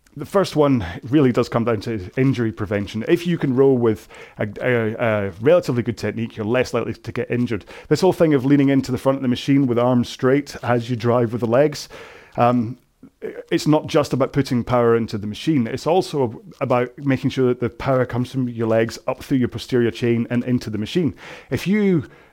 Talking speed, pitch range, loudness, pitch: 215 wpm, 115-140 Hz, -20 LUFS, 125 Hz